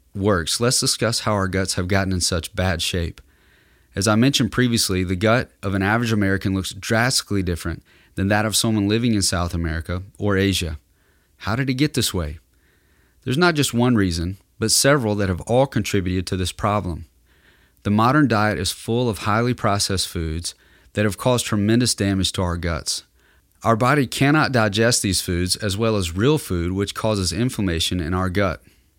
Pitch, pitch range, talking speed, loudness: 100 Hz, 90-115 Hz, 185 wpm, -20 LUFS